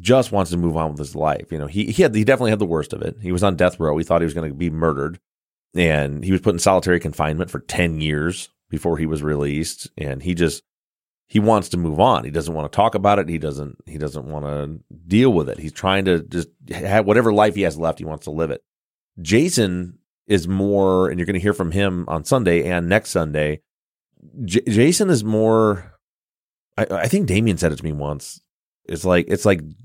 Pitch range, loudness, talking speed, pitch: 80-100 Hz, -20 LUFS, 235 wpm, 85 Hz